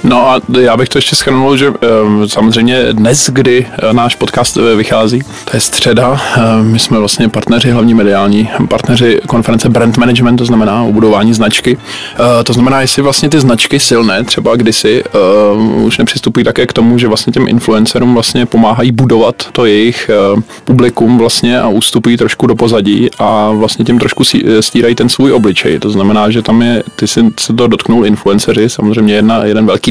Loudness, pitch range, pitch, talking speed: -8 LUFS, 110-125 Hz, 115 Hz, 170 wpm